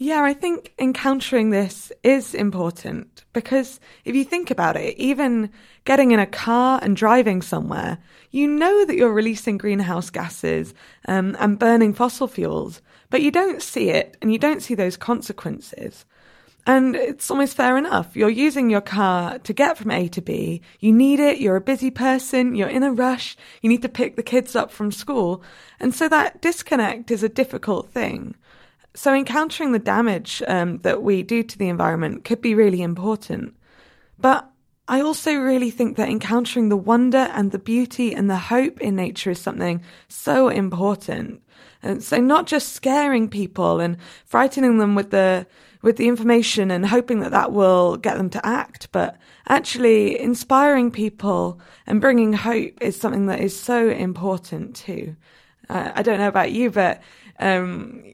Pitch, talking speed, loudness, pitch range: 230 Hz, 175 wpm, -20 LUFS, 200-260 Hz